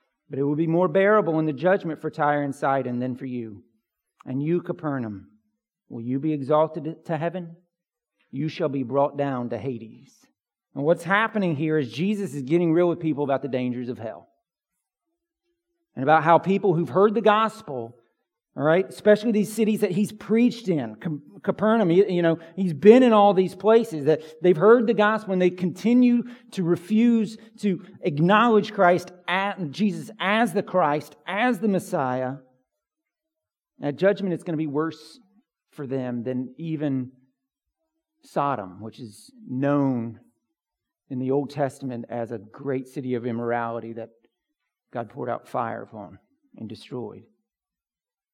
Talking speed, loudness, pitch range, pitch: 160 wpm, -23 LUFS, 135-205 Hz, 165 Hz